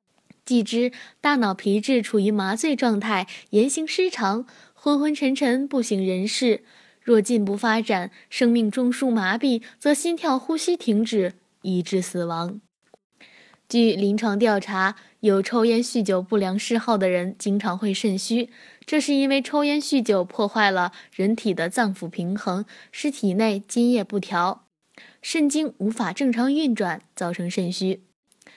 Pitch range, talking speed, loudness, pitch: 195-250 Hz, 220 characters per minute, -23 LUFS, 220 Hz